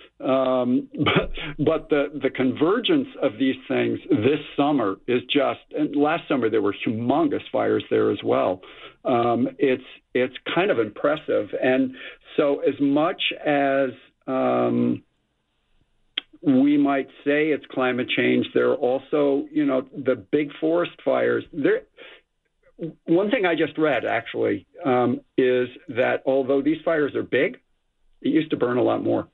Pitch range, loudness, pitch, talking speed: 130-170 Hz, -23 LUFS, 145 Hz, 145 wpm